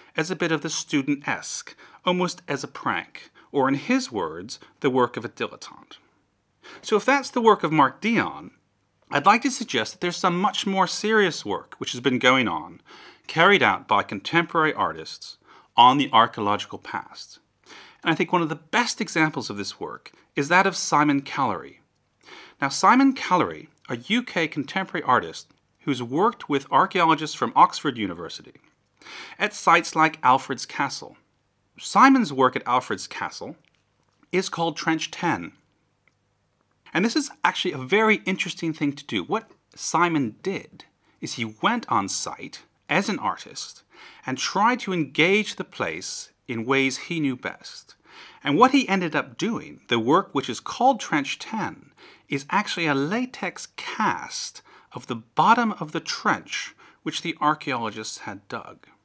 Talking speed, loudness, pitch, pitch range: 160 wpm, -23 LUFS, 165 Hz, 140-210 Hz